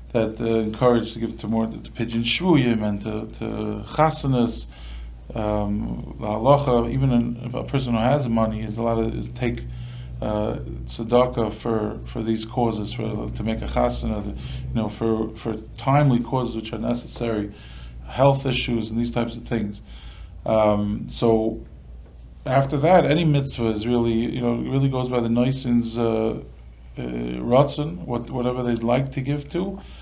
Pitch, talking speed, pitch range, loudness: 115 Hz, 155 wpm, 105-125 Hz, -23 LUFS